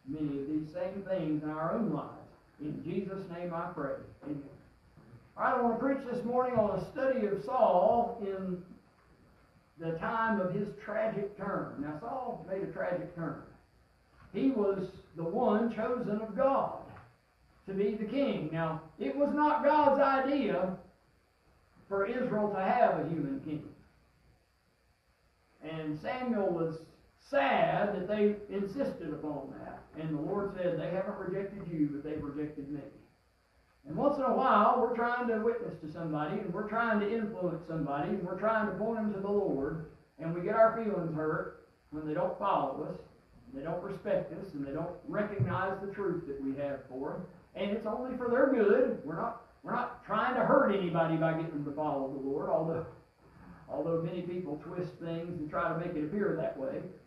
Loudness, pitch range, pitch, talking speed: -33 LUFS, 160-215 Hz, 185 Hz, 185 wpm